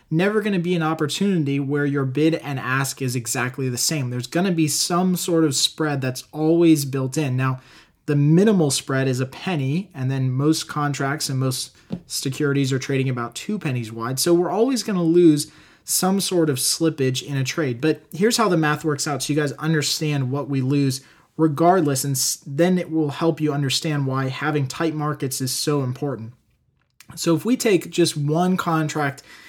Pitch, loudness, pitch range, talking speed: 150 Hz, -21 LUFS, 135-165 Hz, 195 wpm